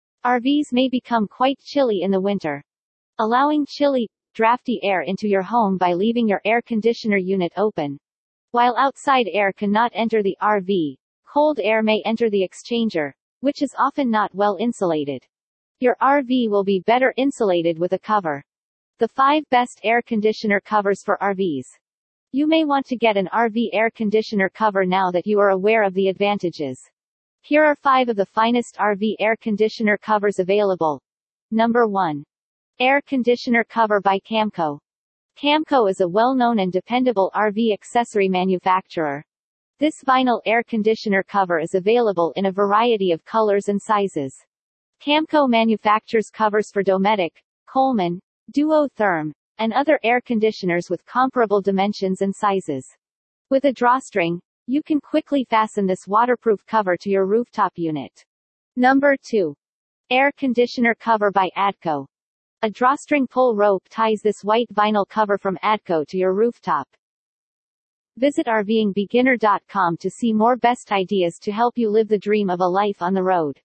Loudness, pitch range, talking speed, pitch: -20 LUFS, 190-240 Hz, 150 wpm, 215 Hz